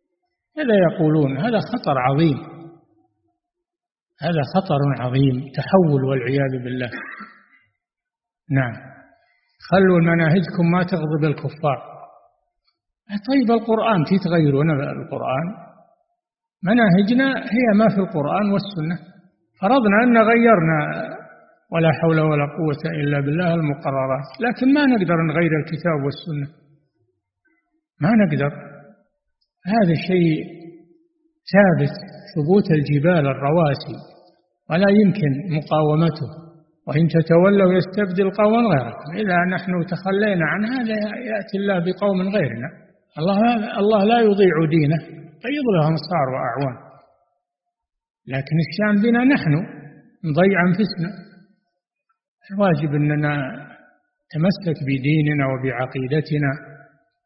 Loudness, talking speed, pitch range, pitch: -19 LUFS, 95 wpm, 150-210 Hz, 170 Hz